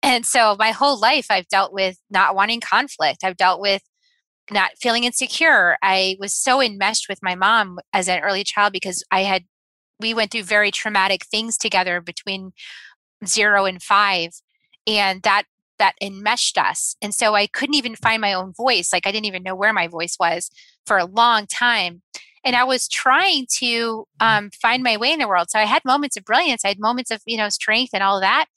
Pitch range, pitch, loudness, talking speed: 190-235 Hz, 210 Hz, -18 LUFS, 205 wpm